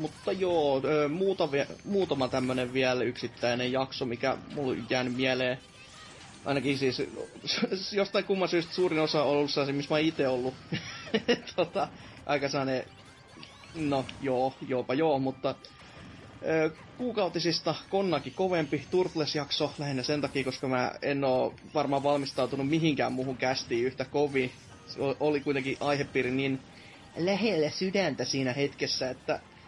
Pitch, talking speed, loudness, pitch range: 140 Hz, 120 wpm, -30 LUFS, 130-160 Hz